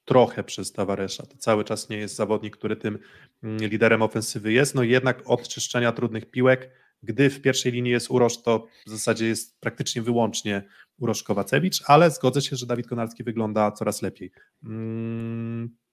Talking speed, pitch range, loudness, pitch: 165 wpm, 110-125 Hz, -24 LUFS, 115 Hz